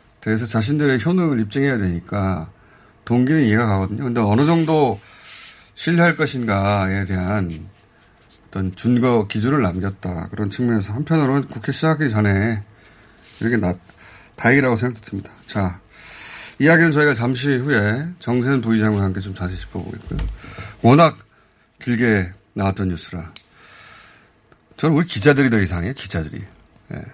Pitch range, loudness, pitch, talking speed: 100-135 Hz, -19 LUFS, 110 Hz, 320 characters per minute